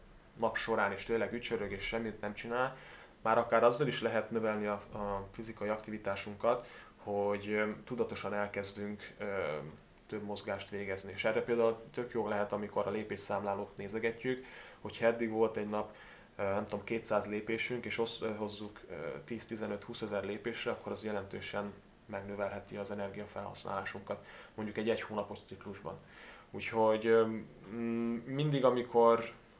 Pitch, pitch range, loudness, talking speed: 110 Hz, 100-115 Hz, -36 LUFS, 130 wpm